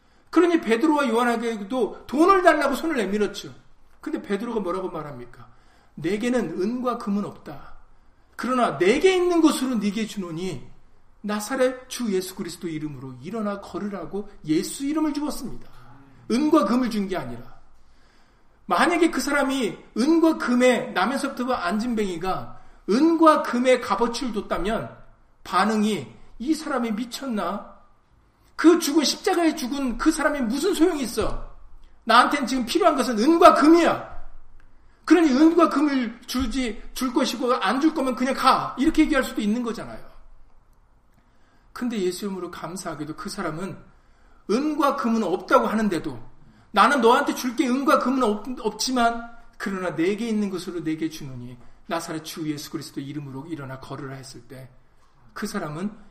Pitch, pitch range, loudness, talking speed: 235 Hz, 185-275 Hz, -23 LUFS, 315 characters per minute